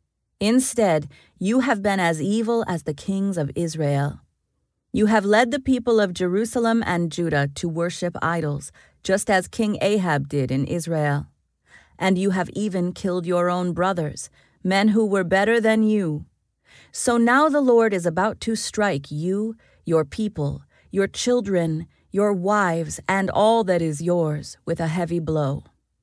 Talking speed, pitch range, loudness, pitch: 155 wpm, 165-215 Hz, -22 LUFS, 185 Hz